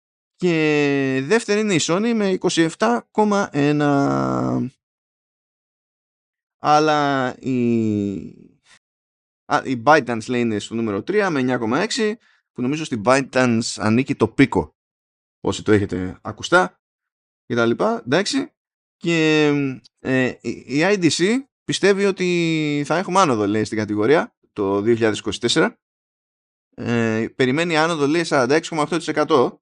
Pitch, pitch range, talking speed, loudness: 140 Hz, 115-165 Hz, 105 wpm, -19 LUFS